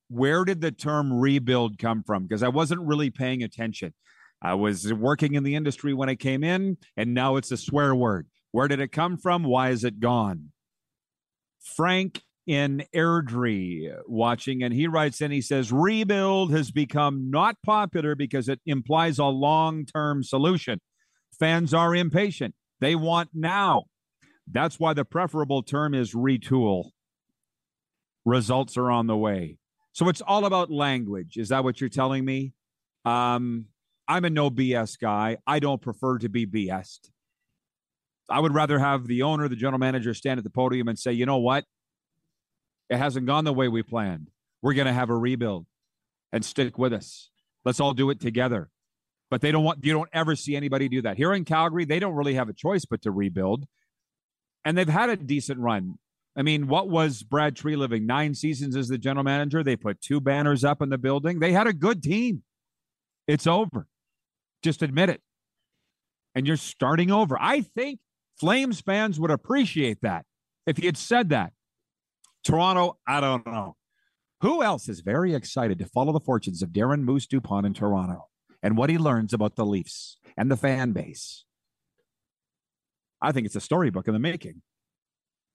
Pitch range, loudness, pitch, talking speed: 120-160 Hz, -25 LUFS, 140 Hz, 180 wpm